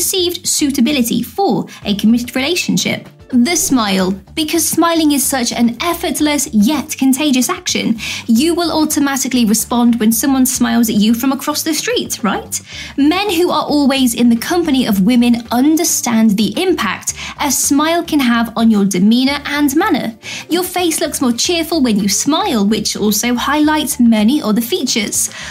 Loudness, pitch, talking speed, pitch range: -14 LUFS, 265 Hz, 155 wpm, 235-315 Hz